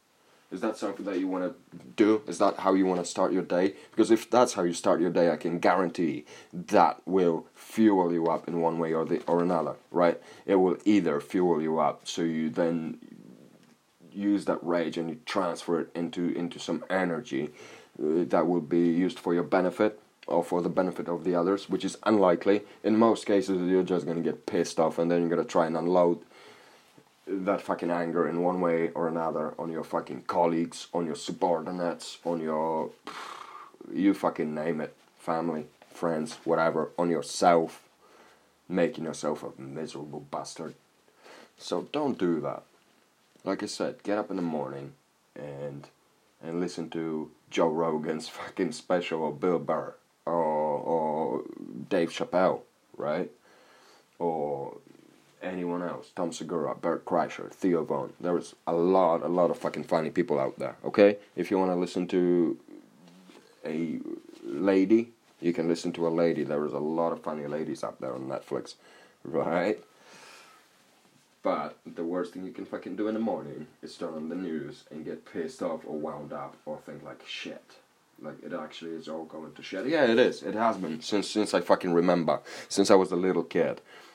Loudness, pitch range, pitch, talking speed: -28 LUFS, 85-95 Hz, 85 Hz, 180 wpm